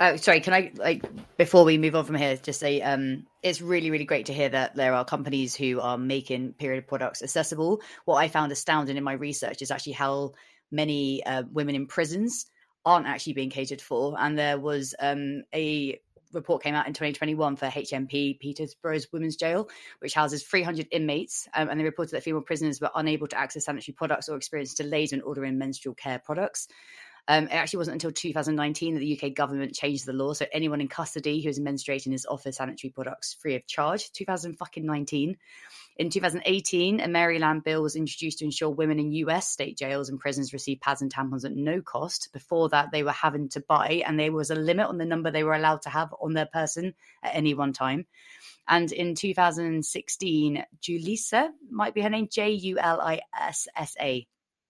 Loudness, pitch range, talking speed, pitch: -27 LUFS, 140-165 Hz, 200 wpm, 150 Hz